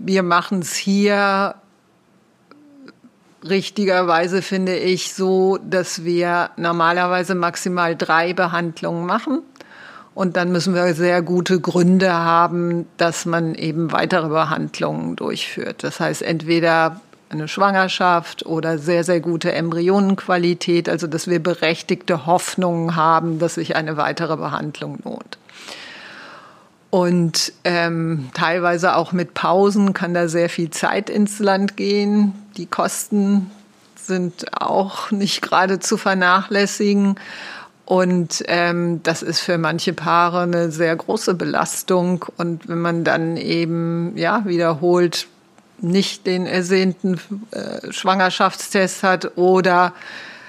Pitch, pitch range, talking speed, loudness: 180 Hz, 170-190 Hz, 115 wpm, -19 LUFS